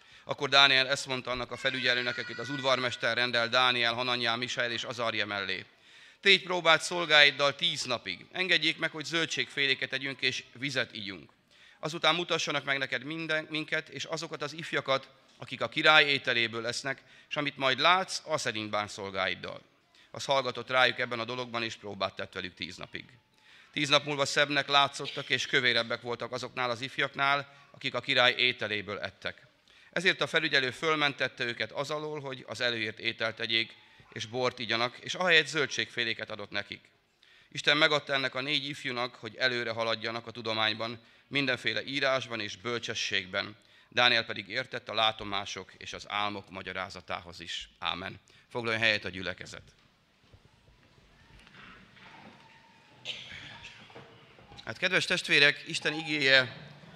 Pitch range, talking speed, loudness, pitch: 115-145 Hz, 145 wpm, -28 LUFS, 125 Hz